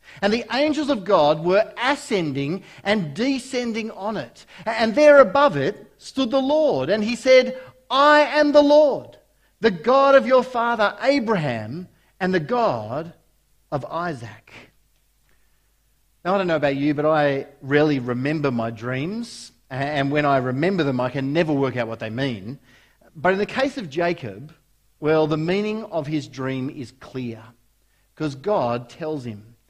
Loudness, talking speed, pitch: -21 LUFS, 160 wpm, 170 Hz